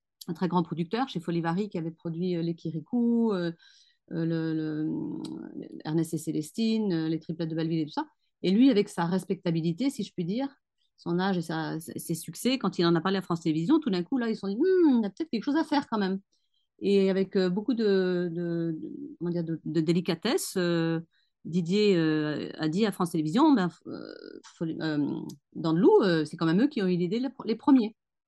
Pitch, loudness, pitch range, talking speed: 180 Hz, -28 LUFS, 165-230 Hz, 215 wpm